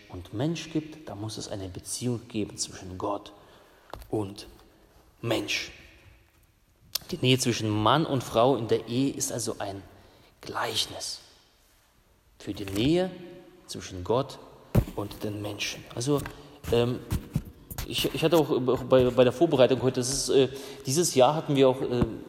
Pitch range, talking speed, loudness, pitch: 105-140 Hz, 140 wpm, -27 LUFS, 120 Hz